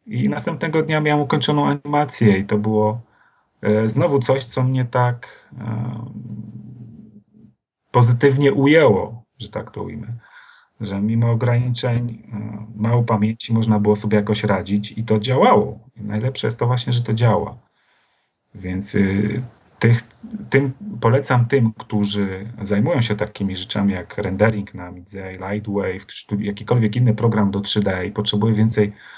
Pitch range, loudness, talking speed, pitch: 105-125 Hz, -19 LUFS, 140 wpm, 110 Hz